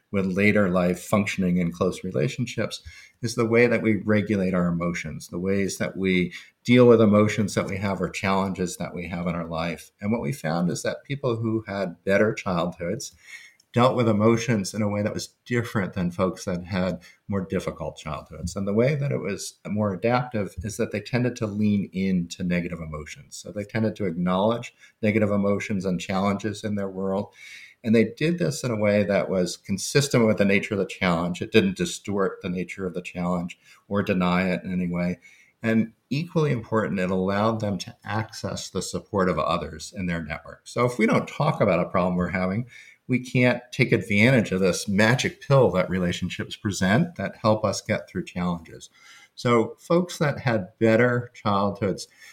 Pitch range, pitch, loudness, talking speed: 90-115 Hz, 100 Hz, -24 LUFS, 190 wpm